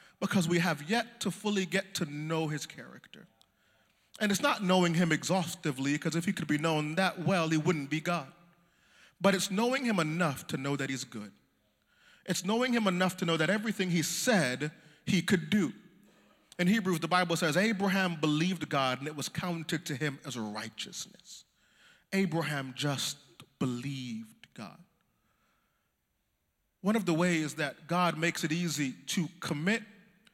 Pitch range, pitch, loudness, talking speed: 150-190 Hz, 170 Hz, -31 LUFS, 165 wpm